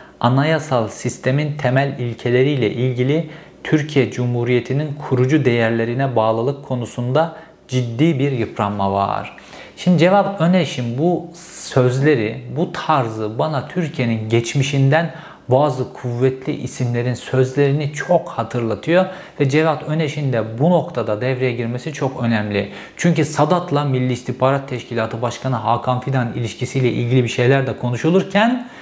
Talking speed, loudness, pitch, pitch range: 115 wpm, -18 LUFS, 130 Hz, 120-155 Hz